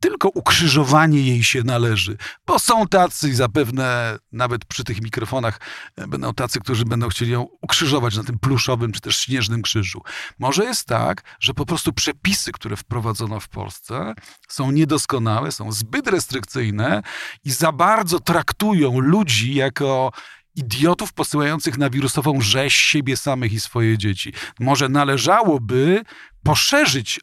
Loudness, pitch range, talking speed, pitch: -19 LUFS, 115-150 Hz, 135 wpm, 130 Hz